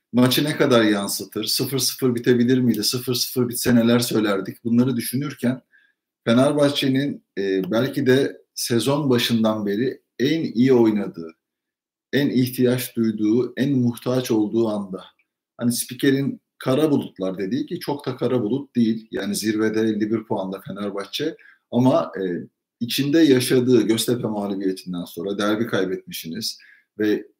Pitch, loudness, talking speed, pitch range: 120 Hz, -21 LUFS, 125 wpm, 105-130 Hz